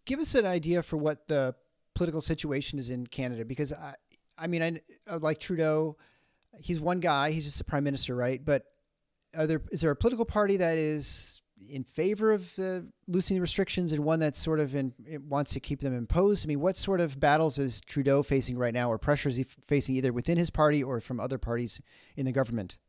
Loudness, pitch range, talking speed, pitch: -30 LUFS, 135-170 Hz, 215 wpm, 150 Hz